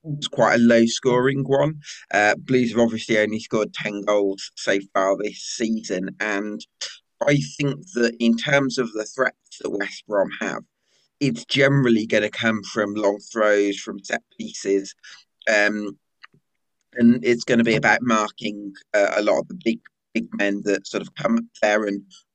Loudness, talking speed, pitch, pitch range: -21 LUFS, 170 wpm, 110 Hz, 105-125 Hz